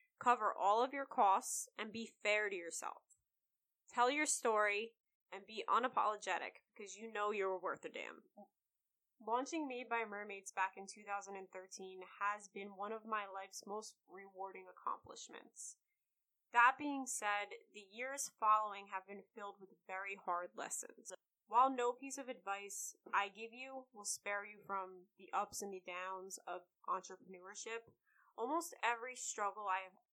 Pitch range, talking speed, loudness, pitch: 195-240 Hz, 150 wpm, -40 LUFS, 210 Hz